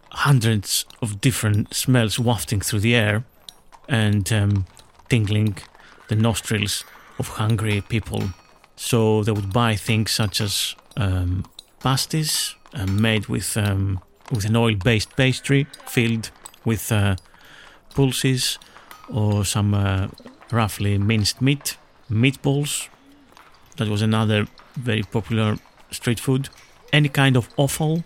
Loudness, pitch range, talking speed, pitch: -22 LUFS, 105-125 Hz, 120 wpm, 110 Hz